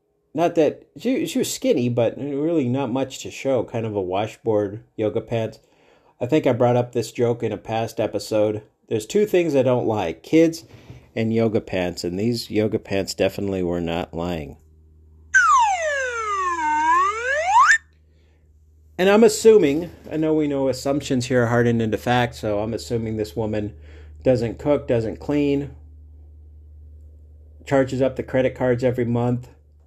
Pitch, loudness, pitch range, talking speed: 120 Hz, -21 LUFS, 90-140 Hz, 155 wpm